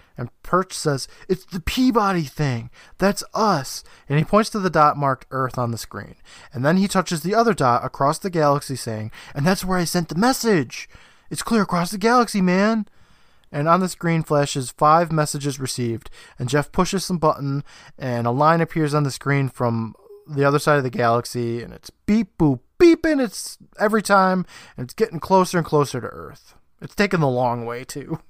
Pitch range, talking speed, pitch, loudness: 130-190 Hz, 195 wpm, 155 Hz, -20 LUFS